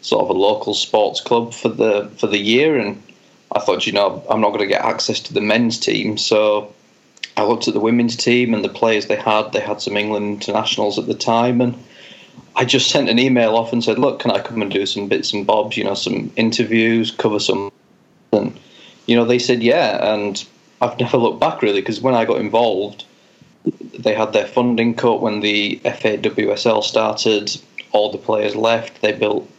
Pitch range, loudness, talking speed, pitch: 105-120 Hz, -17 LUFS, 210 wpm, 115 Hz